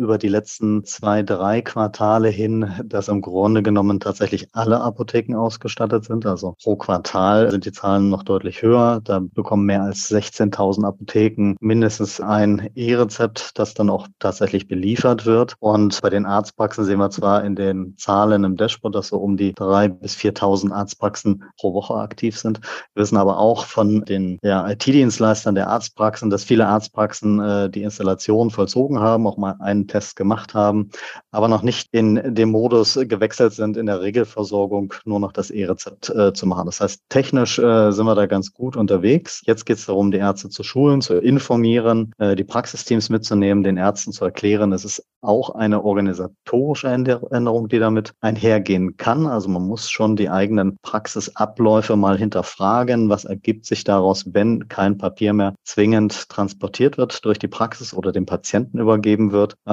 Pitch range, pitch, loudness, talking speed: 100-115 Hz, 105 Hz, -19 LUFS, 175 wpm